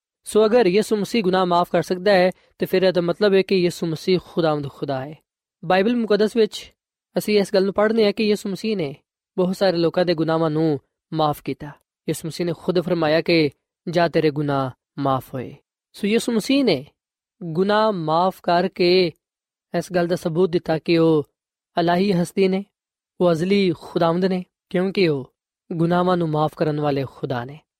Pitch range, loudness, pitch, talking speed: 160-190 Hz, -21 LUFS, 175 Hz, 165 wpm